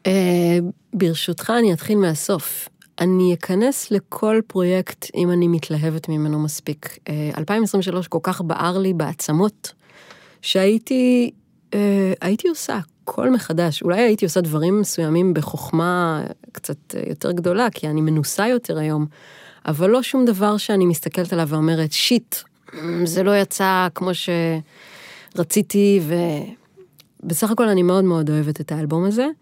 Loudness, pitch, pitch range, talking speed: -20 LUFS, 180 Hz, 165-200 Hz, 130 wpm